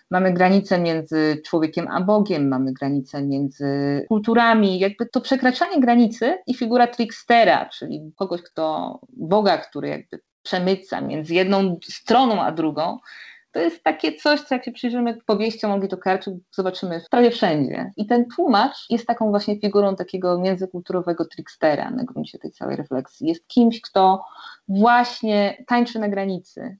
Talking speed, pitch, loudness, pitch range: 145 wpm, 195 Hz, -21 LUFS, 175-235 Hz